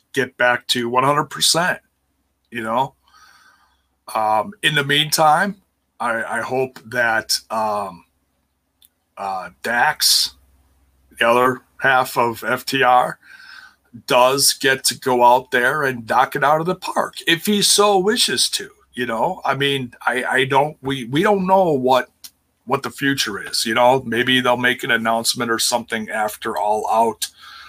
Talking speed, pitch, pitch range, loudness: 145 wpm, 125 Hz, 115-140 Hz, -18 LUFS